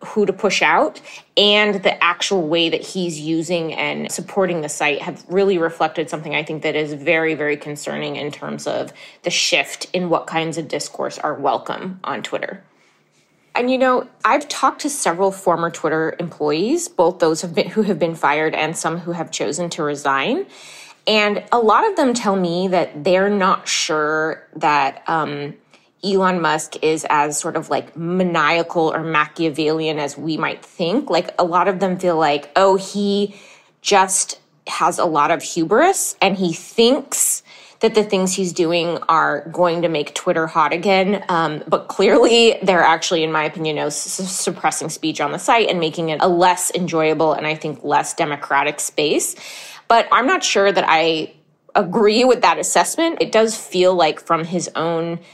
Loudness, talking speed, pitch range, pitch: -18 LUFS, 180 wpm, 160-195 Hz, 170 Hz